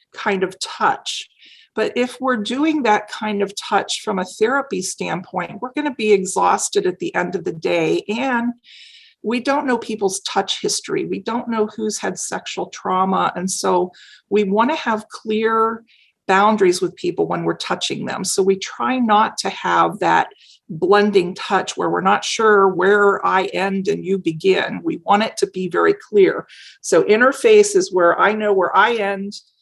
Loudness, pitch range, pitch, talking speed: -18 LUFS, 195-280 Hz, 215 Hz, 180 wpm